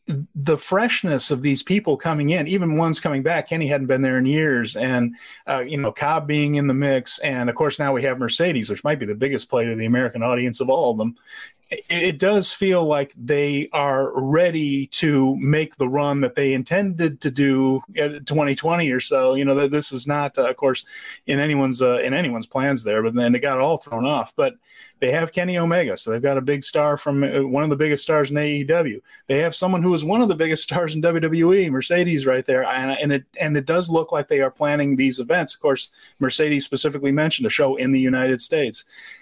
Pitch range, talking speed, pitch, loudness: 135-160 Hz, 230 wpm, 145 Hz, -20 LUFS